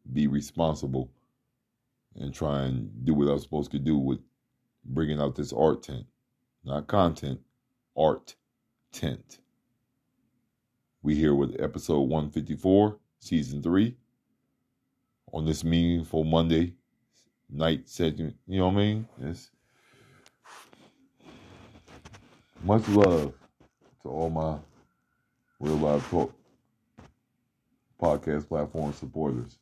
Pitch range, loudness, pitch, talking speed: 70-90 Hz, -28 LUFS, 80 Hz, 105 wpm